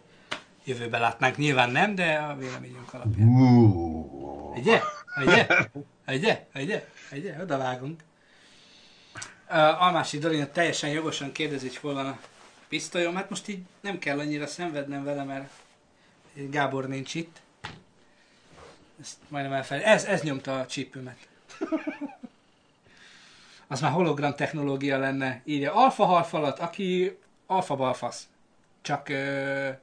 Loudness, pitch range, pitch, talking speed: -26 LUFS, 135-170 Hz, 145 Hz, 115 wpm